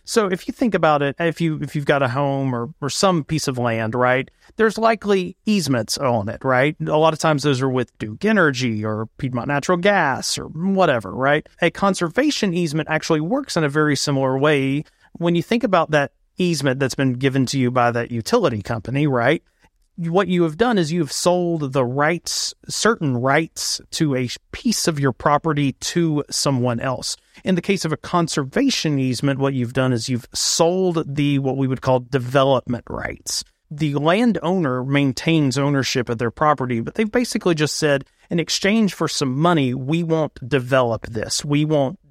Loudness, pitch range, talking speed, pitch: -20 LUFS, 130-170 Hz, 190 wpm, 145 Hz